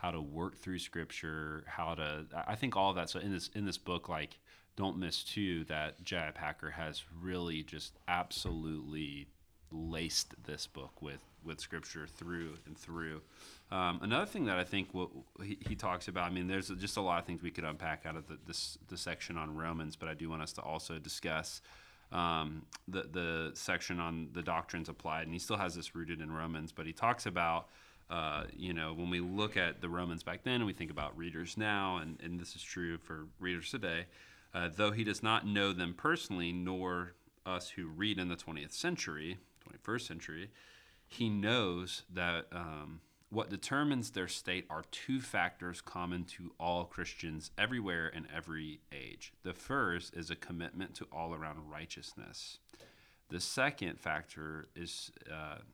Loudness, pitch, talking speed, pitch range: -39 LUFS, 85 Hz, 185 wpm, 80-90 Hz